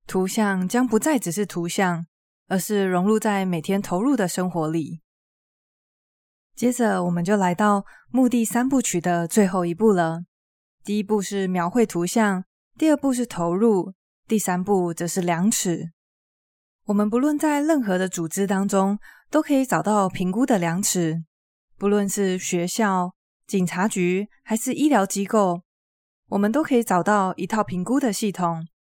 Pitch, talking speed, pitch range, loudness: 195 Hz, 230 characters per minute, 180-220 Hz, -22 LUFS